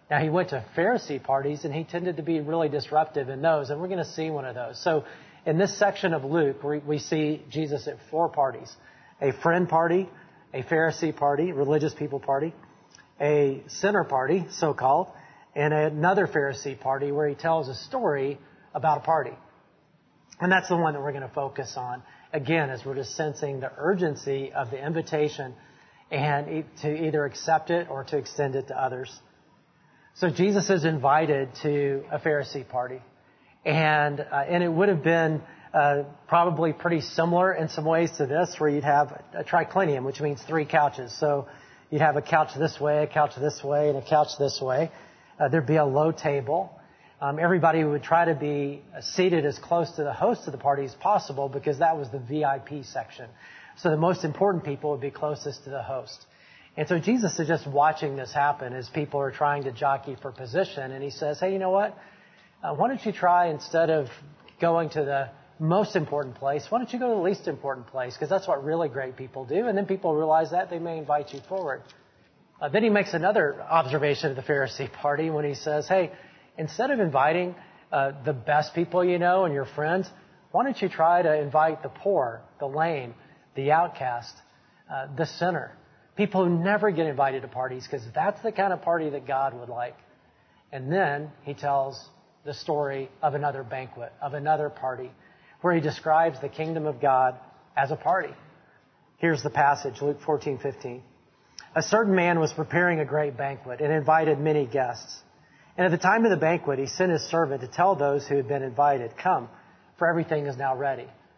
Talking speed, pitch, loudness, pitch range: 195 wpm, 150 Hz, -26 LUFS, 140-170 Hz